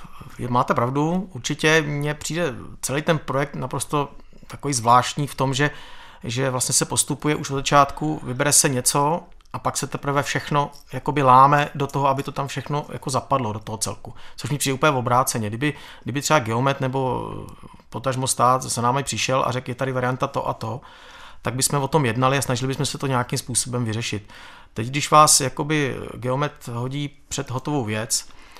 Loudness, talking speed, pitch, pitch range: -21 LUFS, 185 wpm, 135 Hz, 125-145 Hz